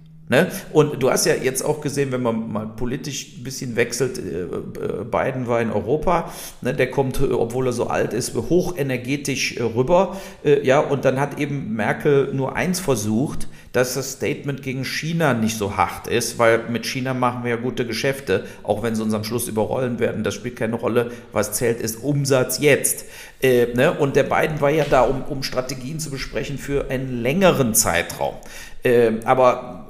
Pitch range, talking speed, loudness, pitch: 115-140 Hz, 180 wpm, -21 LUFS, 130 Hz